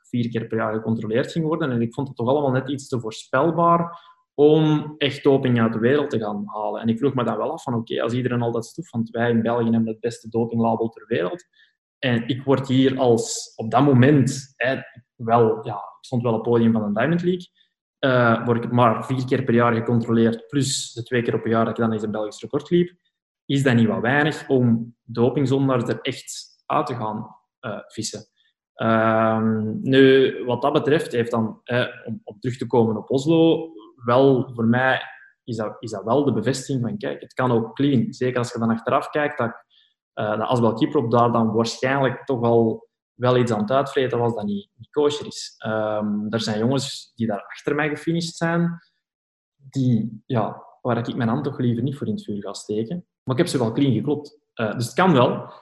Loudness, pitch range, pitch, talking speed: -22 LUFS, 115-140 Hz, 120 Hz, 220 wpm